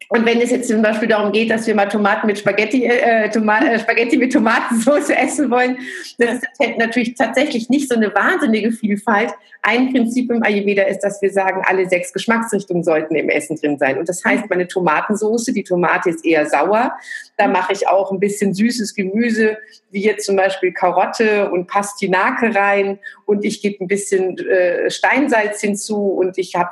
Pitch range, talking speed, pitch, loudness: 195-235 Hz, 195 wpm, 210 Hz, -16 LUFS